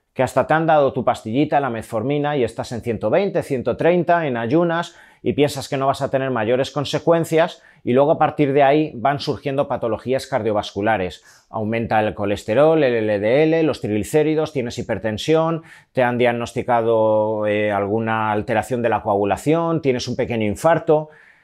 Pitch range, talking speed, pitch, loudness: 110-150 Hz, 160 wpm, 125 Hz, -19 LUFS